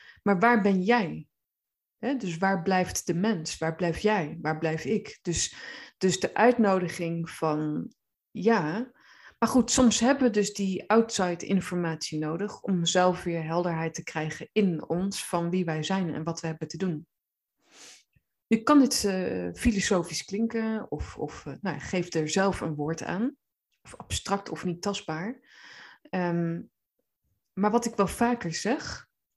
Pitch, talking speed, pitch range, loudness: 185 Hz, 160 wpm, 165-220 Hz, -27 LUFS